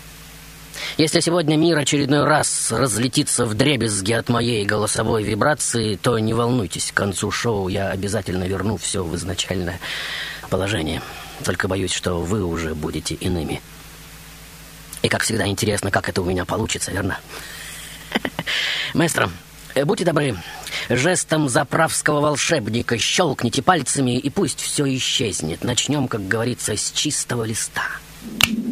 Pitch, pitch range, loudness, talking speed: 115 Hz, 100-145 Hz, -20 LUFS, 125 wpm